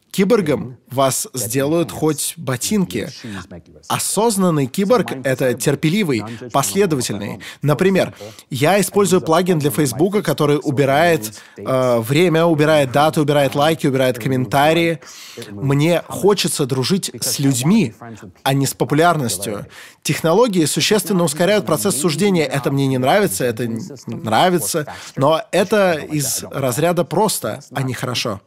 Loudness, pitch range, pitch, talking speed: -17 LUFS, 130-175 Hz, 150 Hz, 115 wpm